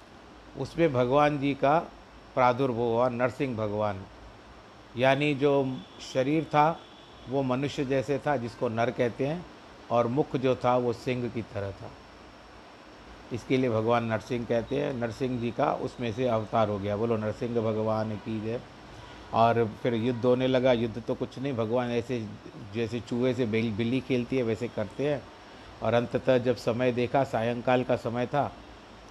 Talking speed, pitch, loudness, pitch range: 160 wpm, 125 Hz, -28 LUFS, 115-130 Hz